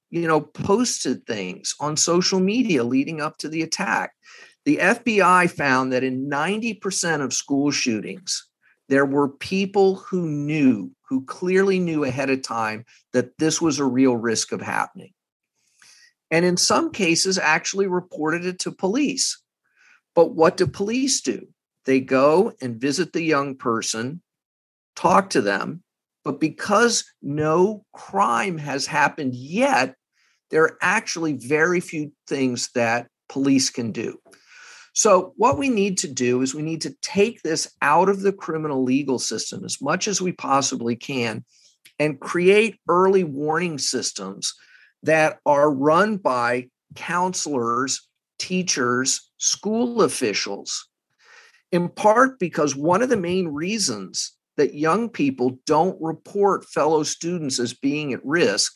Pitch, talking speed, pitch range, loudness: 160 Hz, 140 wpm, 140-195 Hz, -21 LUFS